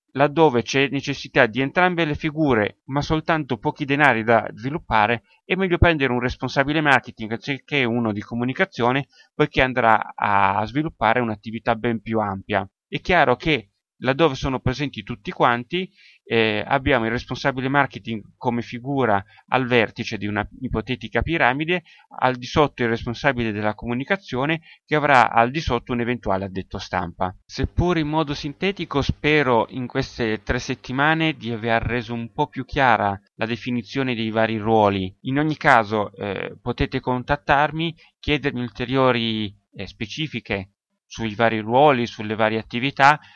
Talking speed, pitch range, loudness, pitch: 145 wpm, 115-145 Hz, -21 LUFS, 125 Hz